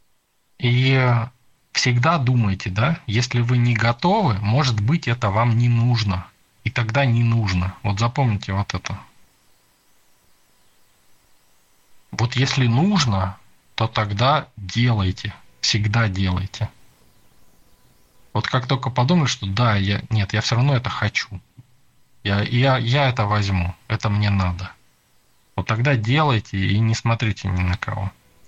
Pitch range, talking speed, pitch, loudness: 100-125 Hz, 125 wpm, 115 Hz, -20 LUFS